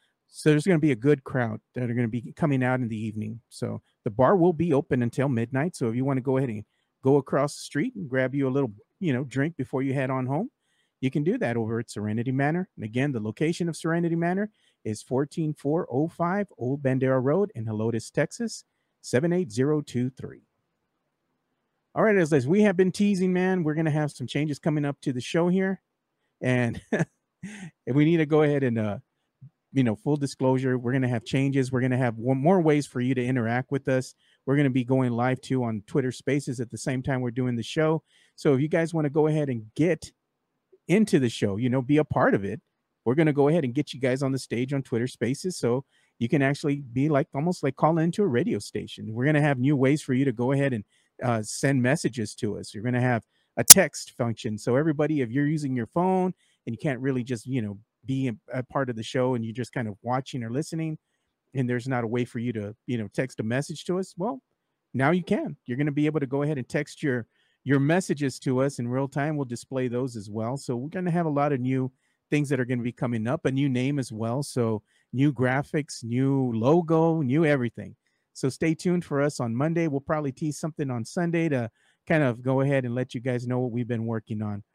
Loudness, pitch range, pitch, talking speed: -26 LUFS, 125-155 Hz, 135 Hz, 240 wpm